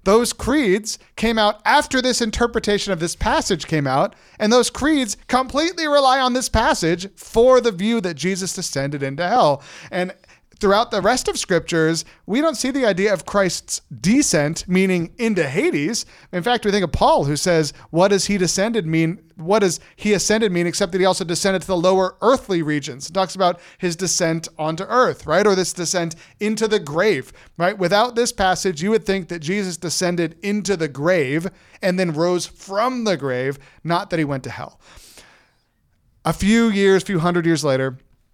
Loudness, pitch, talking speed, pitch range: -19 LUFS, 185 Hz, 190 wpm, 165-215 Hz